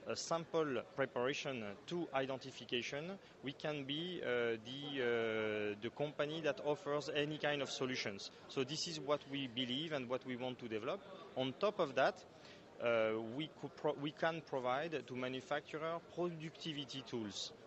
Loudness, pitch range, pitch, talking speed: -41 LUFS, 125-155 Hz, 140 Hz, 155 wpm